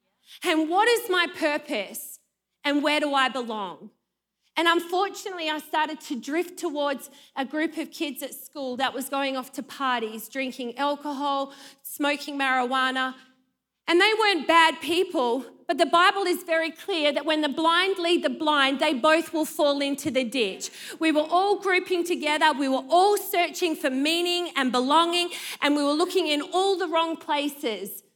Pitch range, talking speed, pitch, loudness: 270-340 Hz, 170 wpm, 300 Hz, -24 LUFS